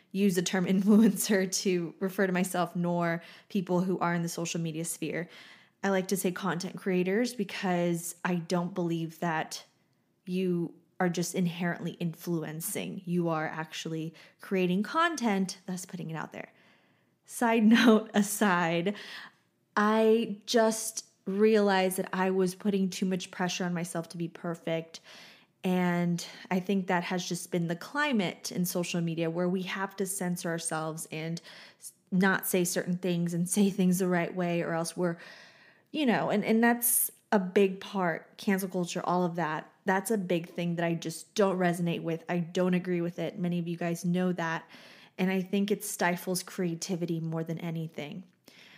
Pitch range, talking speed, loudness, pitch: 170-195 Hz, 165 wpm, -30 LUFS, 180 Hz